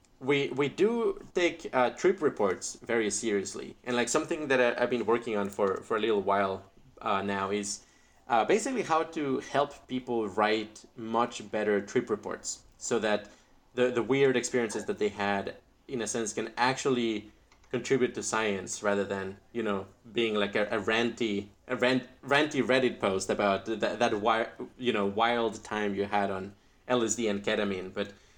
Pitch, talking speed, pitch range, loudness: 110 Hz, 180 wpm, 100-125 Hz, -30 LUFS